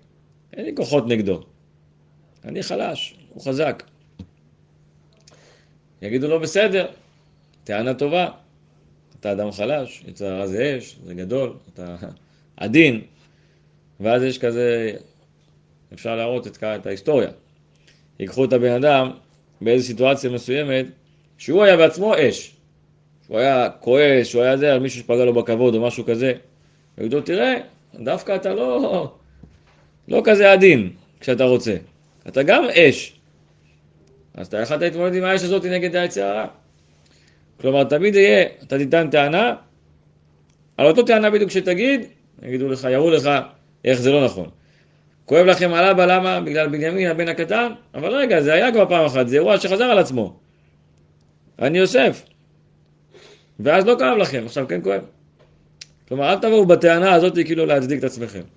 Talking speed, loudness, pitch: 140 wpm, -18 LUFS, 130 Hz